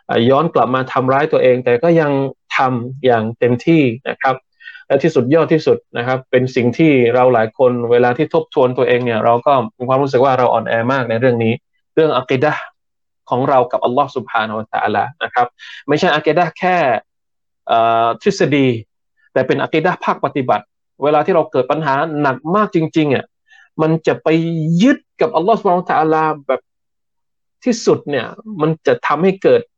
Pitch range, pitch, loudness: 125-165 Hz, 145 Hz, -15 LUFS